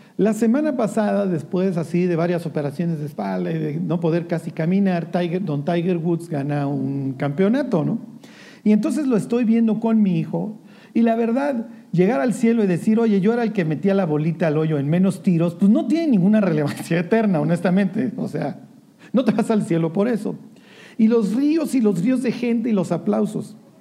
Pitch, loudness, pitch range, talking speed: 200 Hz, -20 LUFS, 170-230 Hz, 200 wpm